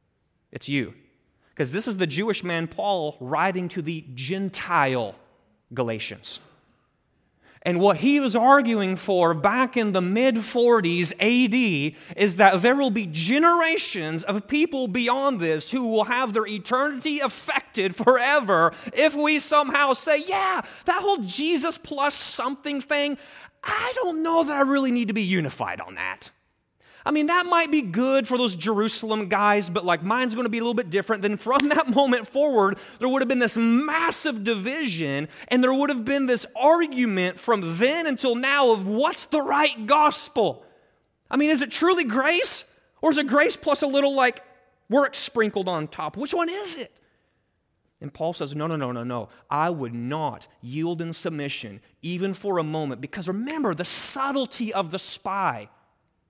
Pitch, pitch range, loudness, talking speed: 235 Hz, 180-280 Hz, -23 LUFS, 170 wpm